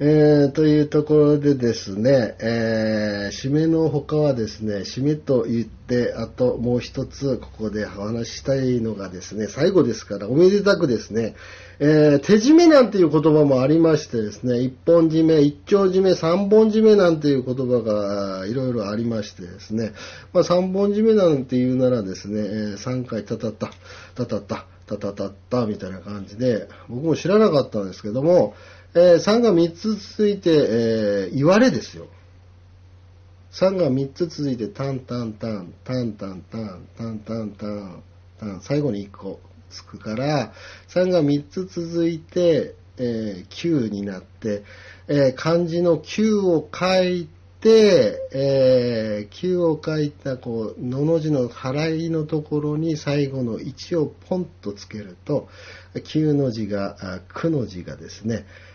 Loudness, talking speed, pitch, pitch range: -20 LUFS, 270 characters per minute, 125 Hz, 100-155 Hz